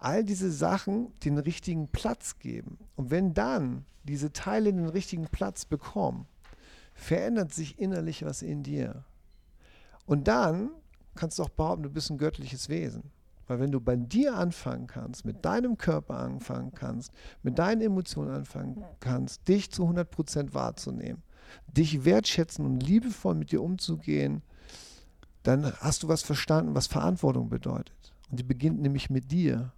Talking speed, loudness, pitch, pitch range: 155 wpm, -30 LUFS, 150 Hz, 115-175 Hz